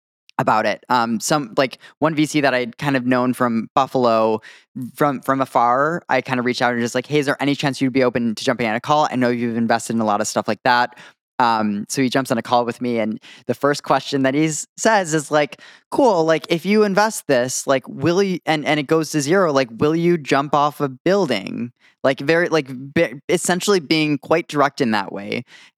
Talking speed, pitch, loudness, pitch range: 230 wpm, 135 Hz, -19 LUFS, 120-155 Hz